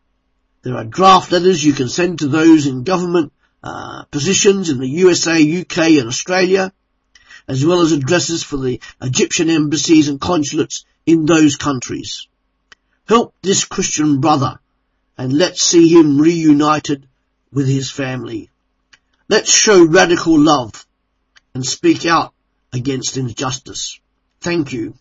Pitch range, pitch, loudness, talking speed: 135-180 Hz, 155 Hz, -14 LUFS, 130 wpm